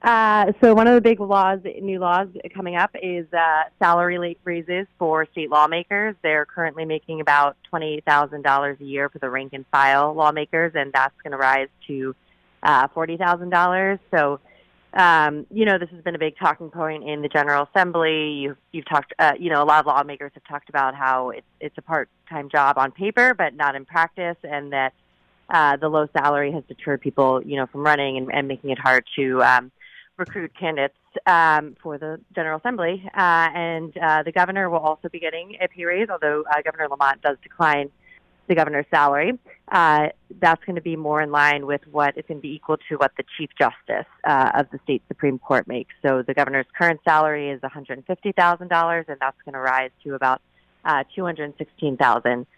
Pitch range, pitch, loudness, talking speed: 140-170 Hz, 150 Hz, -21 LUFS, 200 wpm